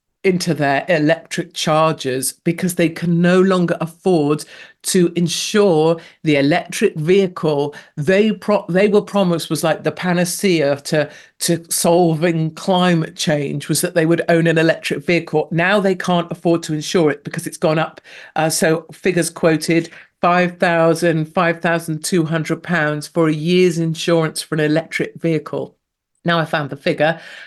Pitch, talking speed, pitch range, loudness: 165 Hz, 155 wpm, 155-175 Hz, -17 LUFS